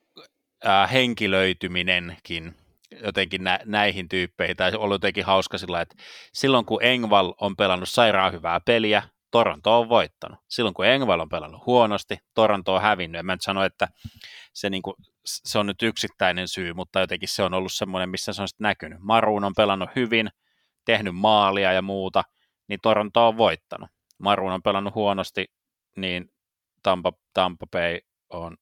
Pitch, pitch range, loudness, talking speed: 100 Hz, 95-105 Hz, -23 LUFS, 160 wpm